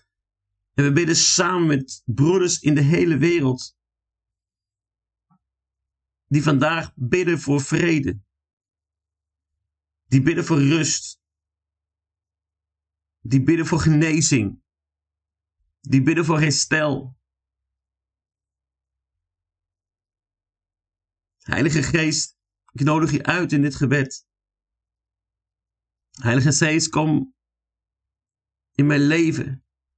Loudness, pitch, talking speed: -20 LUFS, 105 Hz, 85 wpm